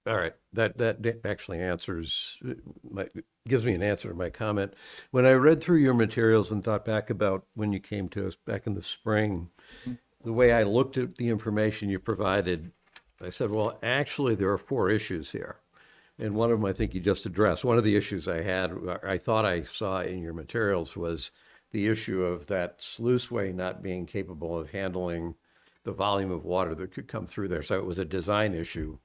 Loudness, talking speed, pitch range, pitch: -28 LUFS, 205 wpm, 90-115 Hz, 100 Hz